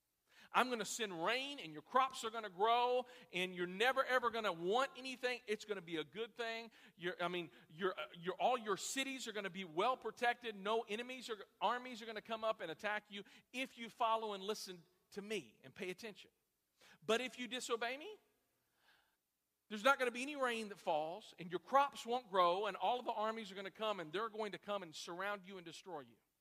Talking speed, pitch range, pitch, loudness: 230 wpm, 190-245 Hz, 220 Hz, -41 LUFS